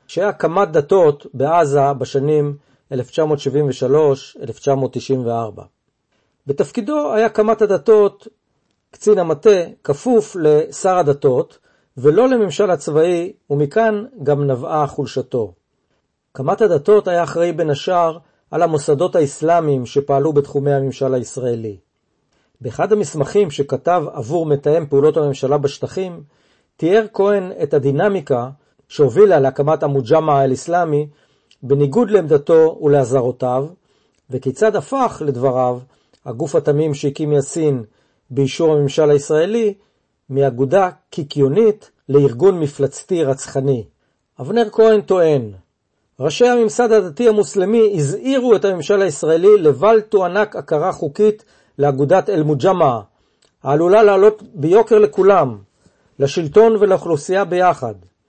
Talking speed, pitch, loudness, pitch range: 95 wpm, 155 Hz, -16 LUFS, 140-205 Hz